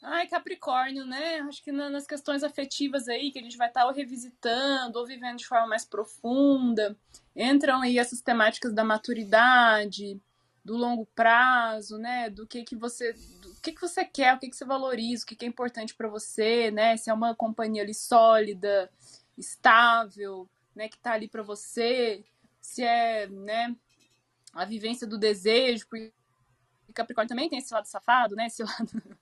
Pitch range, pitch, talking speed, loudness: 220-255 Hz, 235 Hz, 170 wpm, -26 LUFS